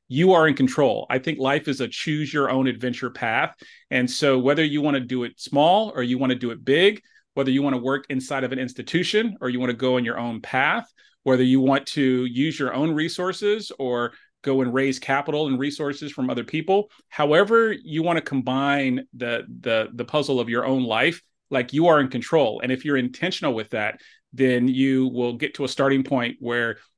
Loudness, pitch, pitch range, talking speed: -22 LUFS, 135 Hz, 125-150 Hz, 220 wpm